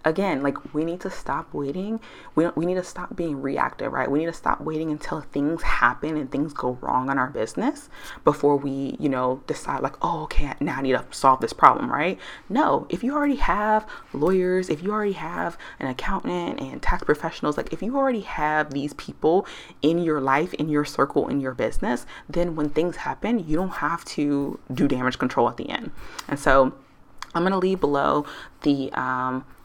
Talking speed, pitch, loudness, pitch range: 200 wpm, 155 Hz, -24 LUFS, 140-185 Hz